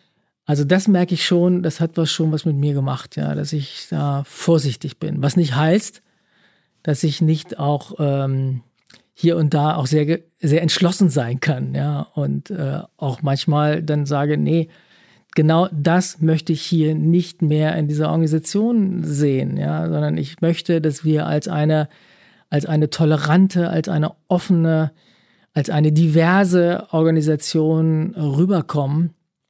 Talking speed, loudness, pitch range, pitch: 150 wpm, -19 LUFS, 150-170 Hz, 155 Hz